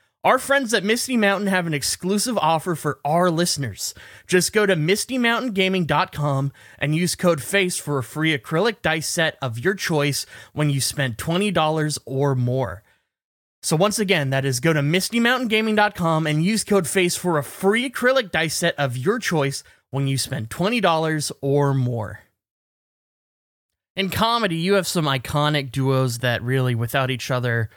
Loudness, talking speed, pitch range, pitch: -21 LUFS, 160 wpm, 135-195 Hz, 160 Hz